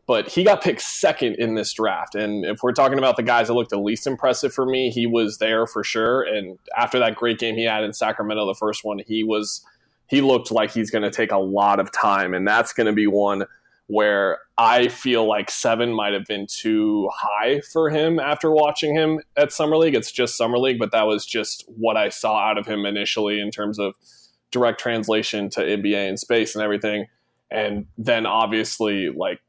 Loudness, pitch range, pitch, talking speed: -21 LUFS, 105-120 Hz, 110 Hz, 215 wpm